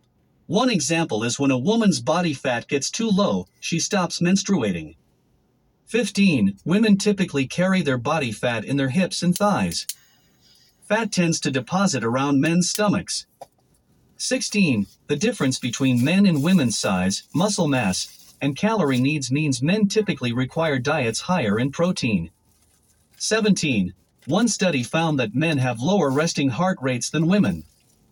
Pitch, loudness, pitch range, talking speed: 155 Hz, -21 LUFS, 130-195 Hz, 145 wpm